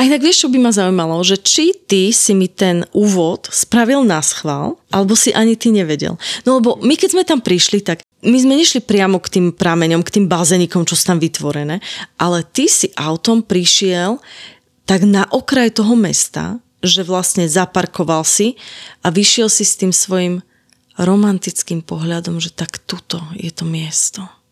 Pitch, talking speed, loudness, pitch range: 190 Hz, 175 wpm, -13 LUFS, 170-225 Hz